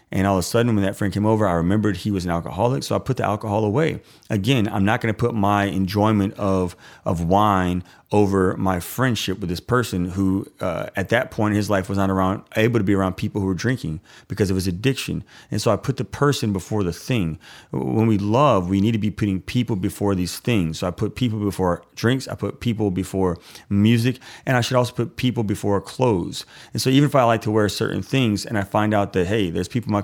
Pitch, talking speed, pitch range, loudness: 105 Hz, 240 wpm, 95-115 Hz, -21 LUFS